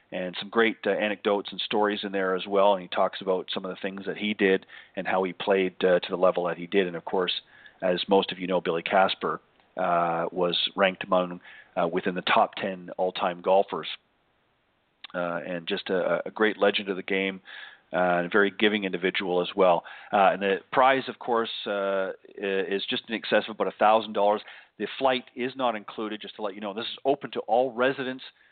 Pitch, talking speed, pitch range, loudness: 100 Hz, 215 wpm, 95-115 Hz, -26 LUFS